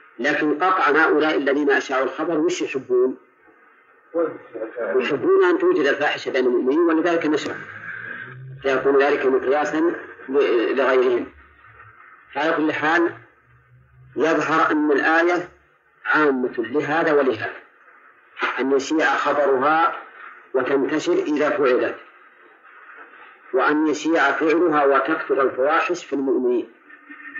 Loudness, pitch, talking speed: -20 LUFS, 305 Hz, 90 wpm